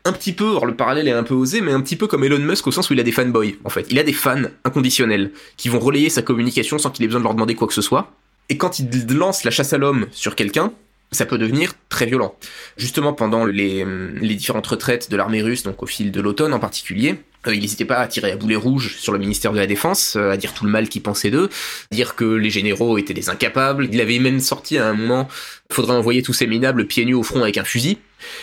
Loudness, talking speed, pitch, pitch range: -19 LUFS, 265 wpm, 120 Hz, 110-135 Hz